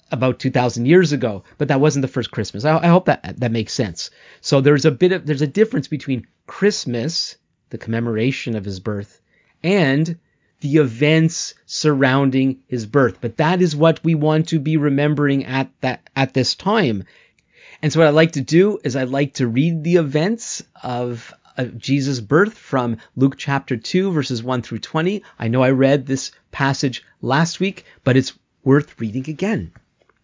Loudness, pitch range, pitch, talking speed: -19 LUFS, 125-160 Hz, 140 Hz, 180 wpm